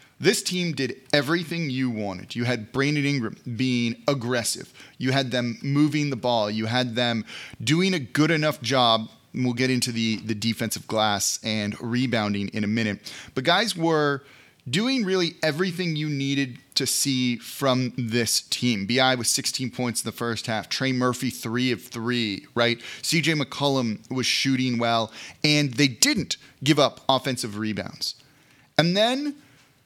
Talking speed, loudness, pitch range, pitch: 160 wpm, -24 LUFS, 115-145 Hz, 125 Hz